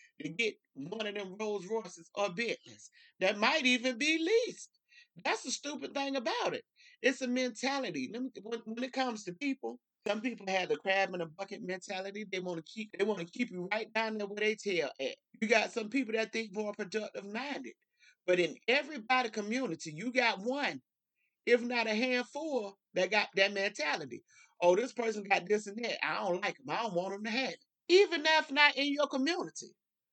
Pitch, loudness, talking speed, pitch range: 230 Hz, -33 LUFS, 205 wpm, 200-270 Hz